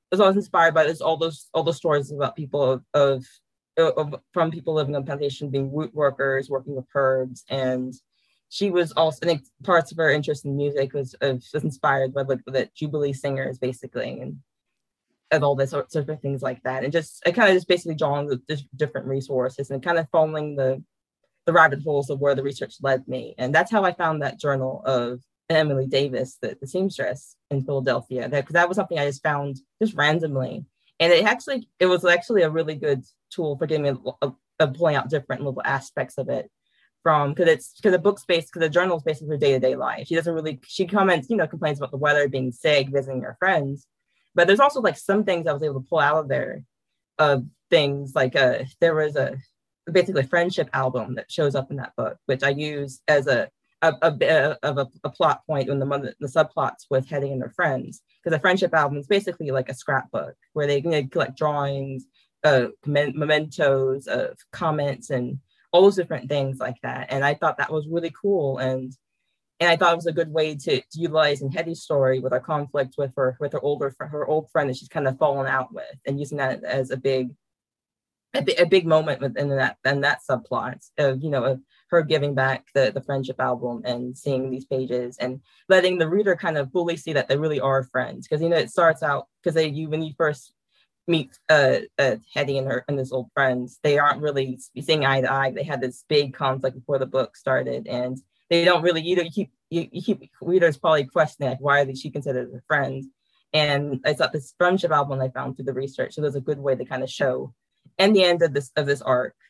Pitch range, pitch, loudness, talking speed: 135-160 Hz, 145 Hz, -23 LUFS, 225 wpm